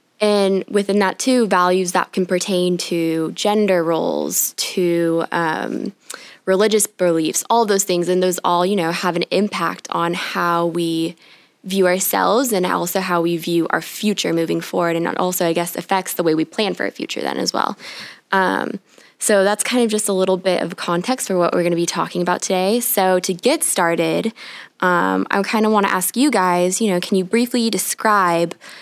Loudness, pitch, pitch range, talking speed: -18 LUFS, 185 Hz, 170-205 Hz, 200 wpm